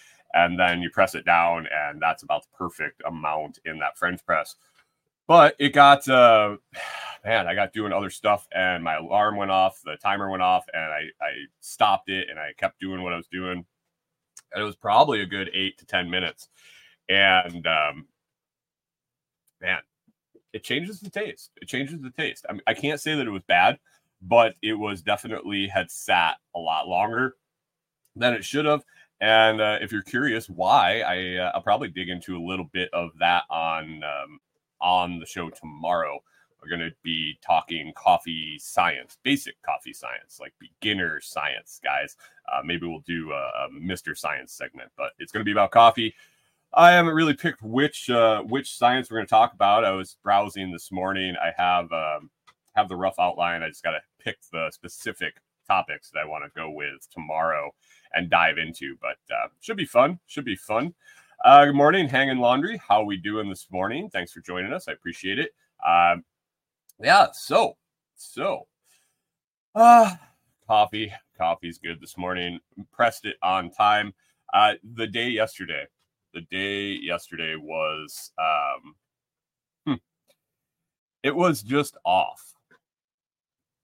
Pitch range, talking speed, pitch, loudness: 90-130 Hz, 170 wpm, 105 Hz, -23 LUFS